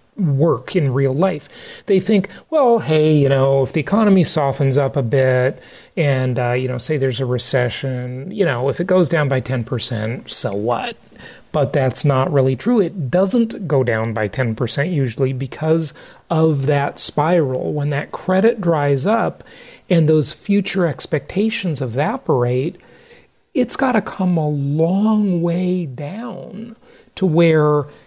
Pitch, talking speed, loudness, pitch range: 150 Hz, 150 wpm, -18 LUFS, 135-185 Hz